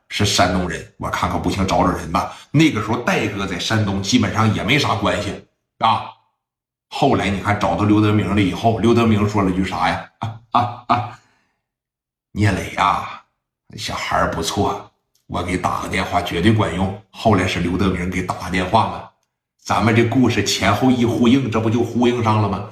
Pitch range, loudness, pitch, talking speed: 90-115 Hz, -18 LUFS, 105 Hz, 275 characters per minute